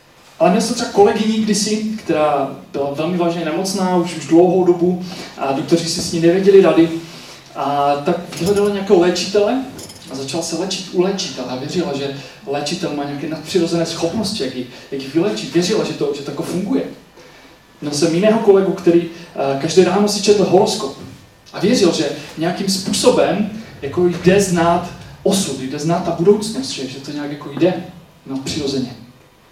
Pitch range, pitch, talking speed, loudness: 145-195 Hz, 170 Hz, 160 wpm, -17 LUFS